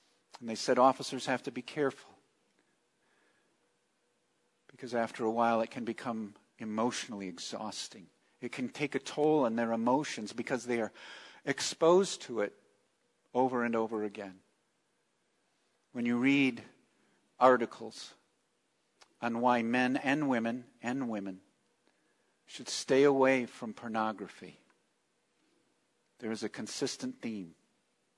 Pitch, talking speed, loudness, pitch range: 120 Hz, 120 wpm, -32 LUFS, 110-130 Hz